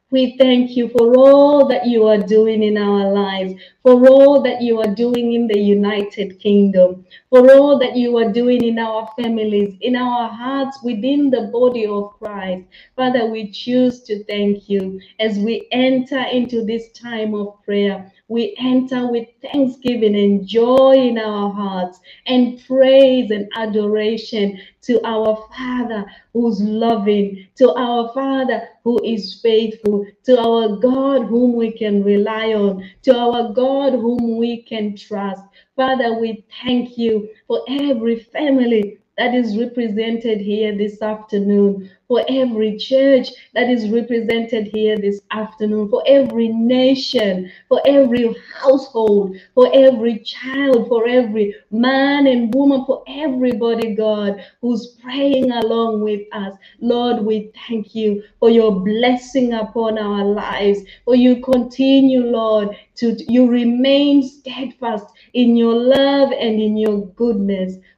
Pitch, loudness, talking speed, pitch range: 230 Hz, -16 LUFS, 140 wpm, 210-250 Hz